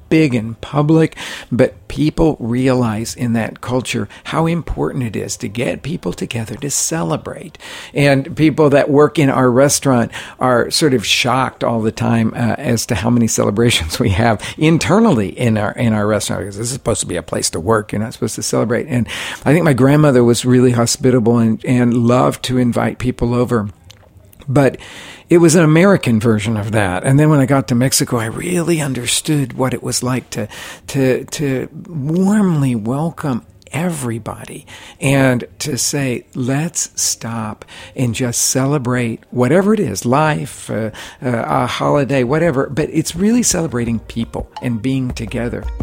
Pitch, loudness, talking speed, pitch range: 125 Hz, -15 LUFS, 170 wpm, 115-145 Hz